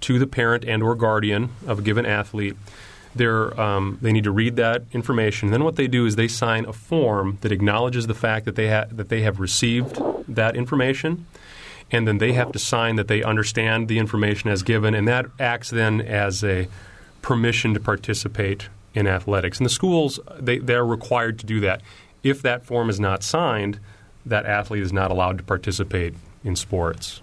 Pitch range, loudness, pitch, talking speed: 100-120 Hz, -22 LUFS, 110 Hz, 195 wpm